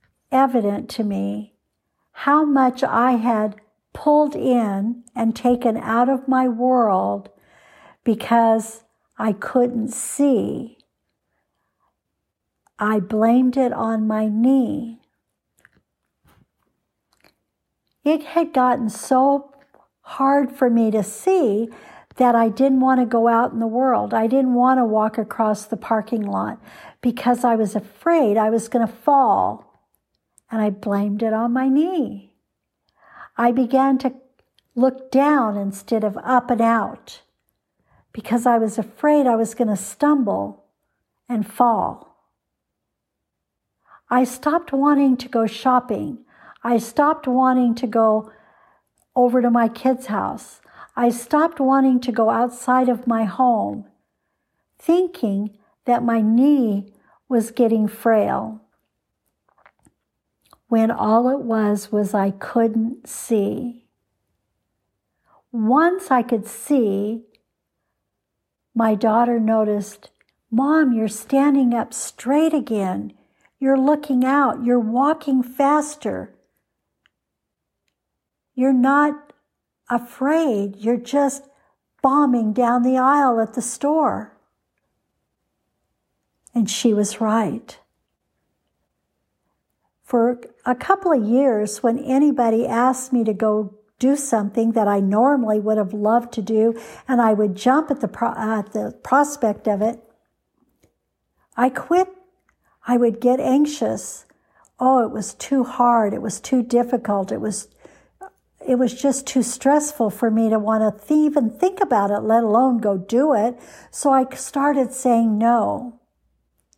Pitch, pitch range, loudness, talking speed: 240 Hz, 220-265 Hz, -19 LUFS, 125 wpm